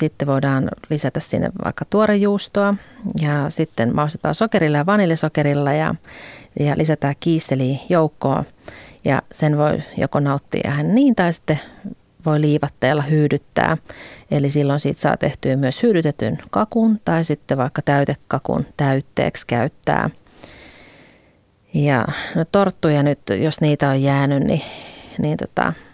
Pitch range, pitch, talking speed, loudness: 140-165 Hz, 150 Hz, 125 wpm, -19 LUFS